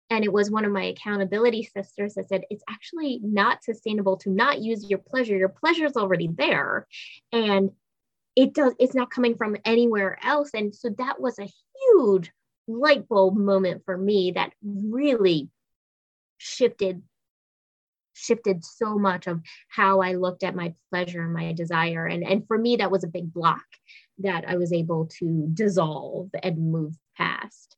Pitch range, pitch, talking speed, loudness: 180-225 Hz, 195 Hz, 170 wpm, -24 LUFS